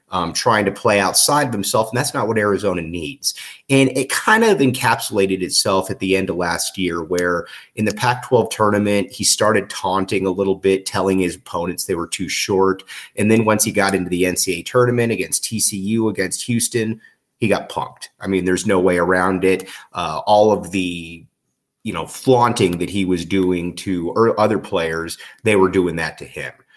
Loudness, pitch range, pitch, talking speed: -18 LUFS, 90-110 Hz, 95 Hz, 195 wpm